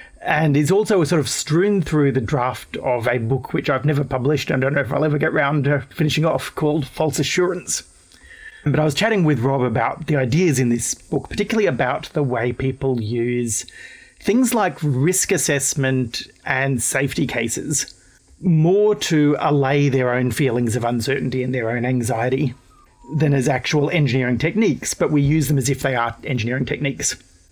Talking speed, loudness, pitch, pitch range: 180 wpm, -19 LUFS, 140 Hz, 130-155 Hz